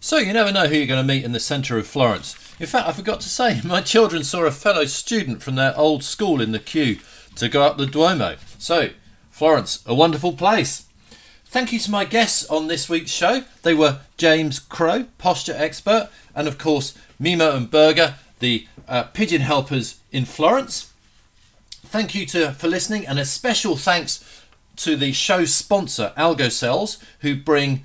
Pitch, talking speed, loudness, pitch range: 150 Hz, 185 wpm, -20 LUFS, 135-175 Hz